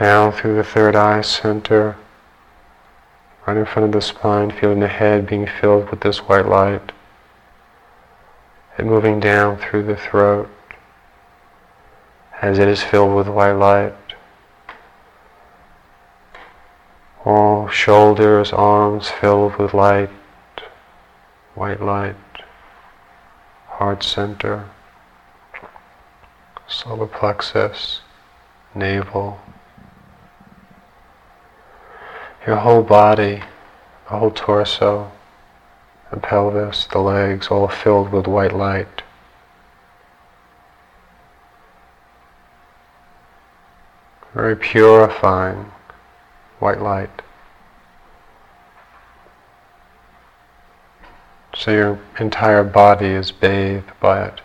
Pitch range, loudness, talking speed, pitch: 90-105 Hz, -16 LUFS, 80 wpm, 100 Hz